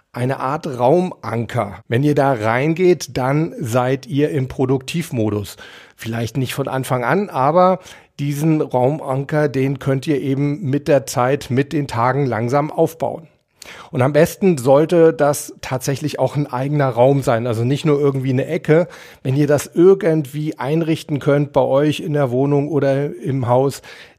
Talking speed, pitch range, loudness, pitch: 155 wpm, 130-150 Hz, -18 LUFS, 140 Hz